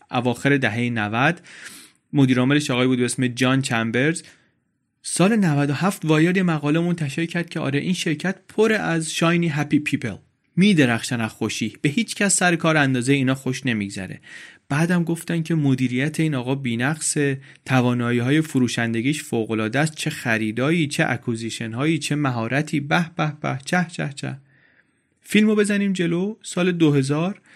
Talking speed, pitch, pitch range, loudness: 150 wpm, 145 Hz, 125-165 Hz, -21 LUFS